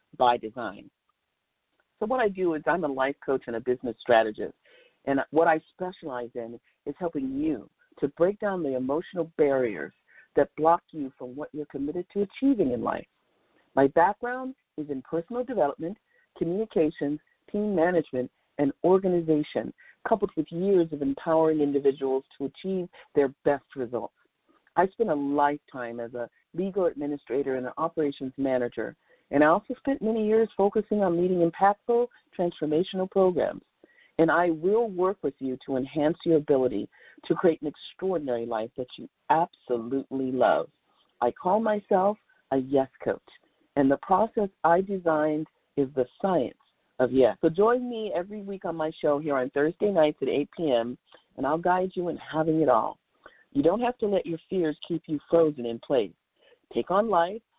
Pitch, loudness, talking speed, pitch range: 160 Hz, -27 LUFS, 165 wpm, 135-190 Hz